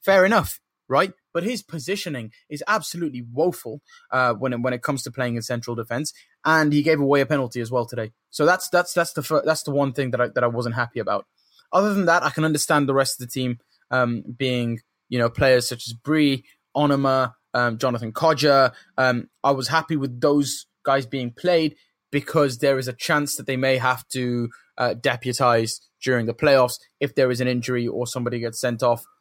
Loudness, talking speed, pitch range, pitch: -22 LUFS, 205 wpm, 125-150 Hz, 135 Hz